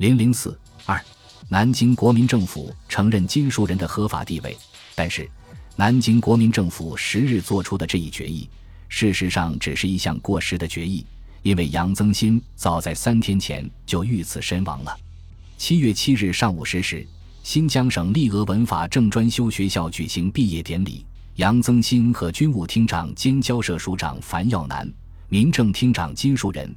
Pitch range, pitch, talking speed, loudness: 85-115 Hz, 100 Hz, 260 characters per minute, -21 LUFS